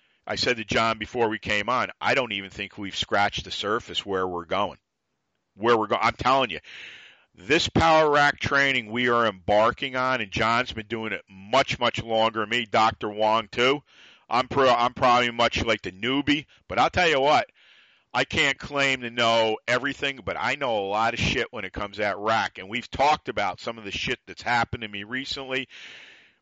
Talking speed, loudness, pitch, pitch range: 205 wpm, -24 LUFS, 115 Hz, 105-130 Hz